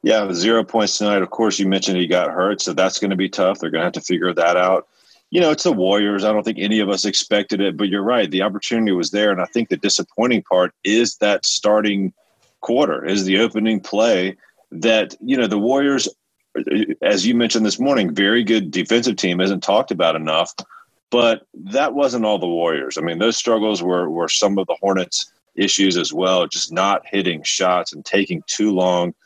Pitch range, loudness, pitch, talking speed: 95-110 Hz, -18 LUFS, 100 Hz, 215 wpm